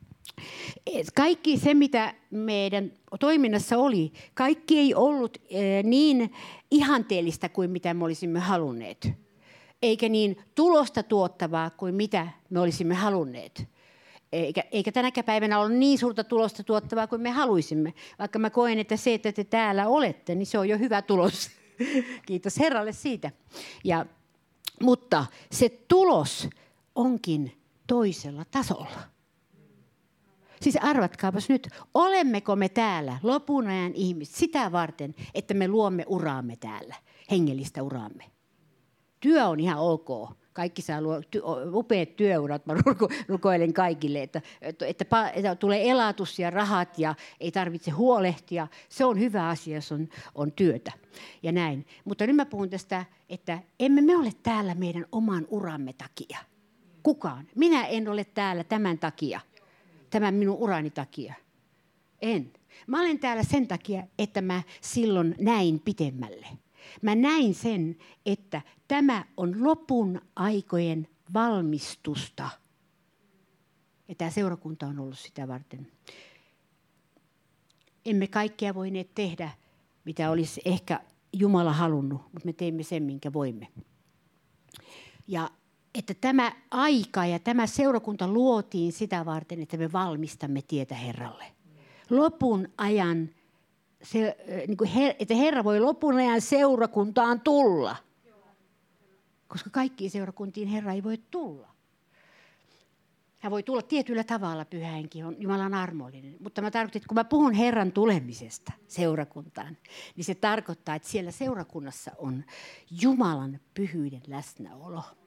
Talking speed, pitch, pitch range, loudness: 125 wpm, 190 Hz, 165-225 Hz, -27 LUFS